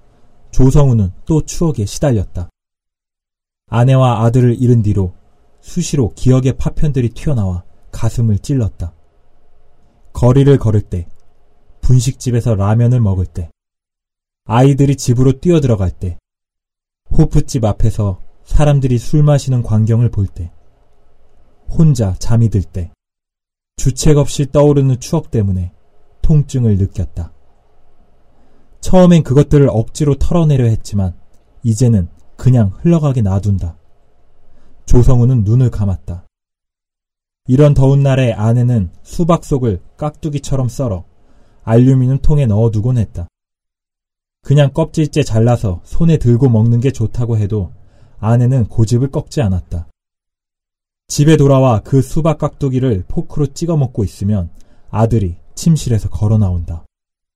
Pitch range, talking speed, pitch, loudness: 95-135 Hz, 265 characters per minute, 115 Hz, -14 LUFS